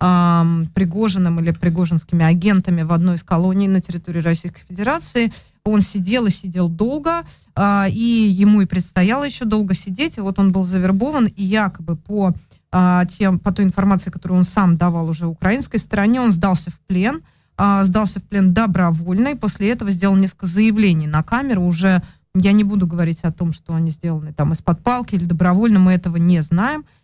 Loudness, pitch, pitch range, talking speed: -17 LUFS, 190 Hz, 175-205 Hz, 175 wpm